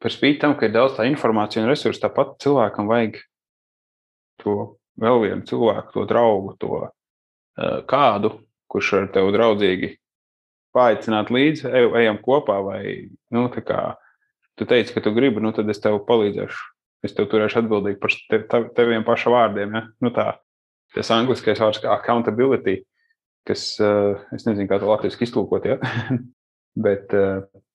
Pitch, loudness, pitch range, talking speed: 110 Hz, -20 LUFS, 100-120 Hz, 140 wpm